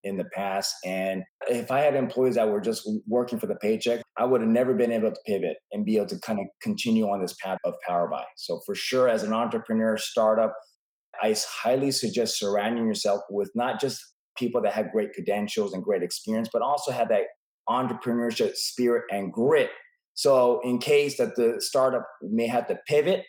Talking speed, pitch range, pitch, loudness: 200 wpm, 105-130 Hz, 115 Hz, -26 LUFS